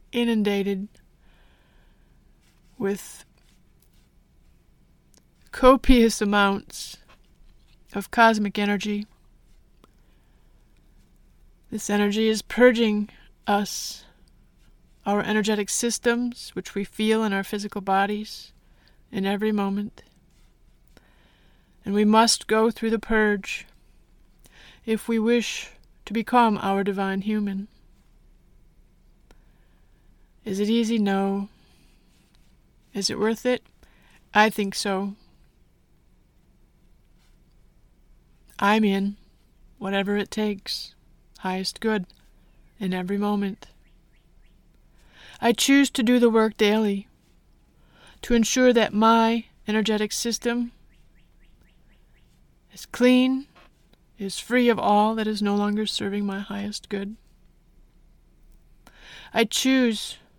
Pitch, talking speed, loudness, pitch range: 210 Hz, 90 wpm, -23 LUFS, 200-225 Hz